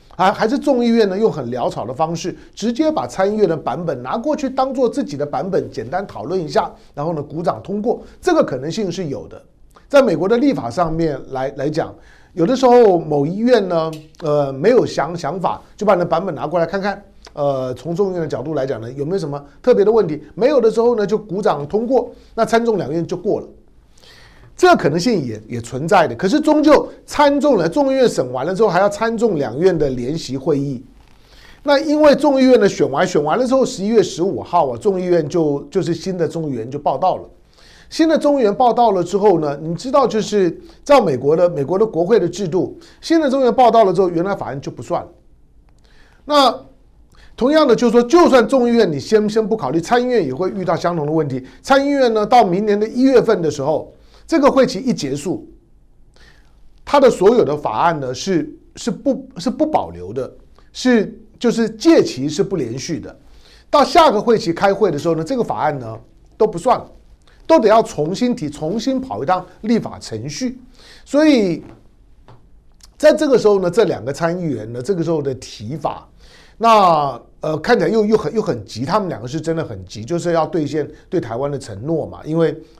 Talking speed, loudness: 300 characters per minute, -17 LUFS